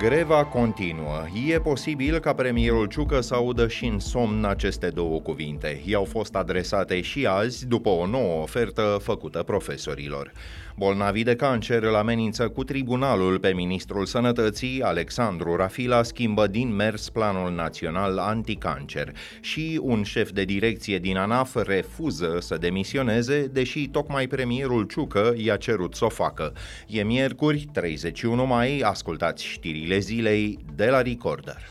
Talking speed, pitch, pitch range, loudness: 140 wpm, 110 Hz, 95-125 Hz, -25 LUFS